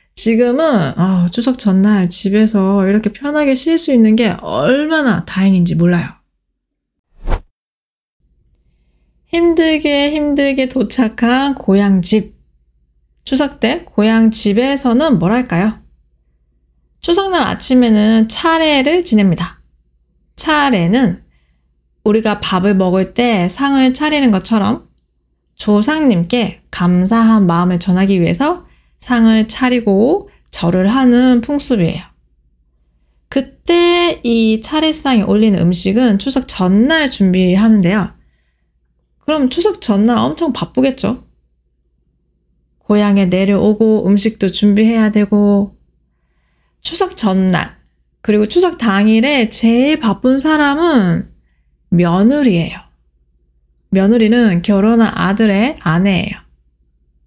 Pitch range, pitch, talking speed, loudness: 170-250 Hz, 210 Hz, 220 characters per minute, -13 LUFS